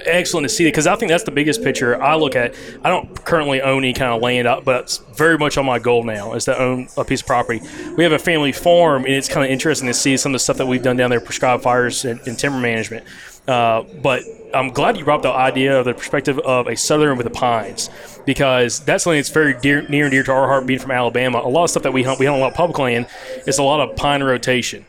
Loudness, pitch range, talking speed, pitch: -17 LUFS, 125-145 Hz, 280 wpm, 135 Hz